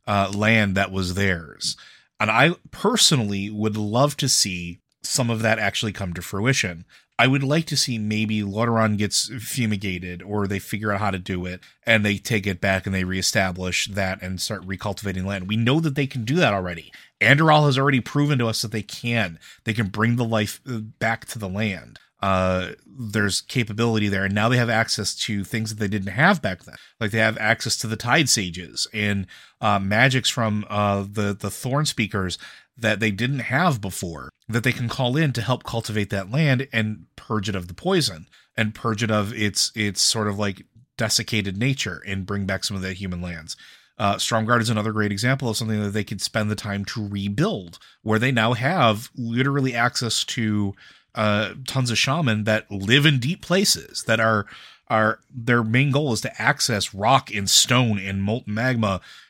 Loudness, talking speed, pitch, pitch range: -22 LUFS, 200 wpm, 110 Hz, 100-120 Hz